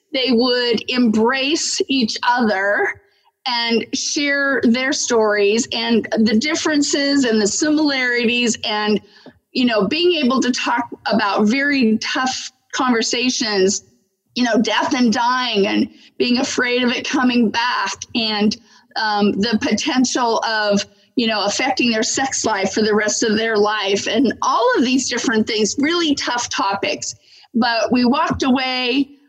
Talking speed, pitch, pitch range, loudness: 140 wpm, 245 Hz, 220-275 Hz, -17 LUFS